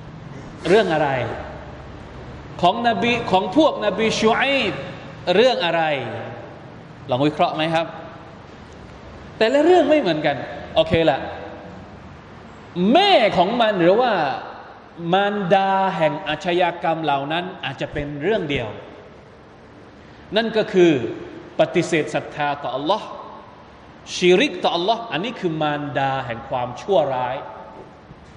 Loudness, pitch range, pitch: -20 LUFS, 145-205 Hz, 165 Hz